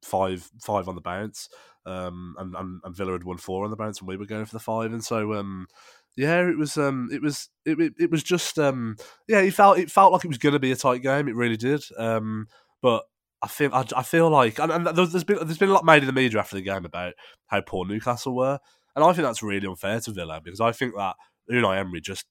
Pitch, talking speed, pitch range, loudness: 115 Hz, 265 wpm, 95-150 Hz, -24 LUFS